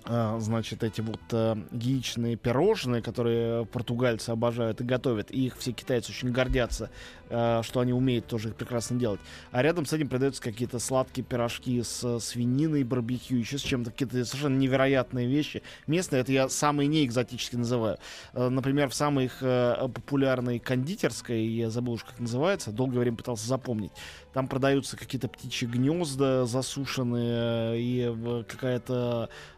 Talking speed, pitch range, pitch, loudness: 155 wpm, 115-130 Hz, 125 Hz, -29 LUFS